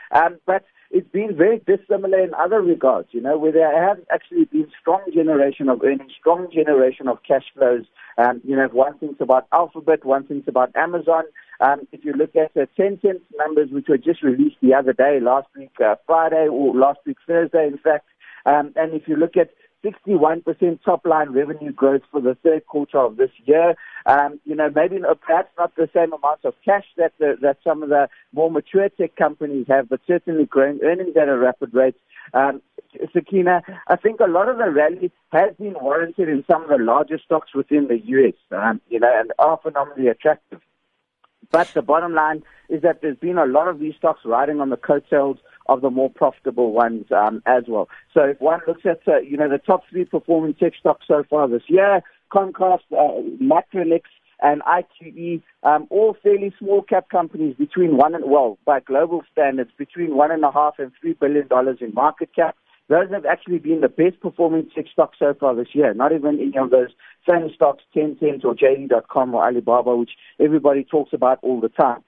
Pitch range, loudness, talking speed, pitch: 140-175 Hz, -19 LUFS, 205 wpm, 155 Hz